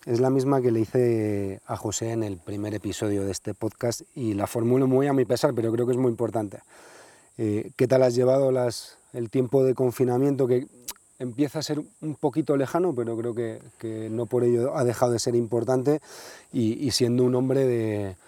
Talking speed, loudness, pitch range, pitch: 205 wpm, -25 LUFS, 115-130 Hz, 120 Hz